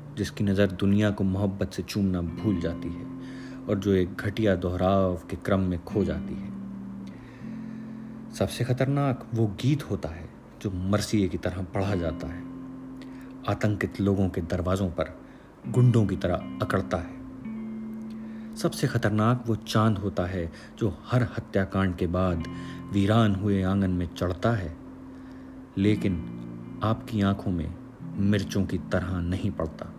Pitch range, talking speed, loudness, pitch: 90-125 Hz, 140 wpm, -27 LUFS, 100 Hz